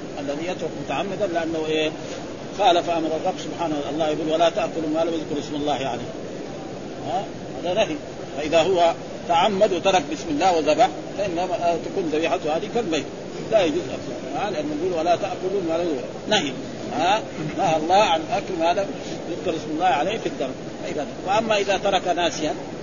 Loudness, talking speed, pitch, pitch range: -23 LUFS, 165 wpm, 165 Hz, 155-185 Hz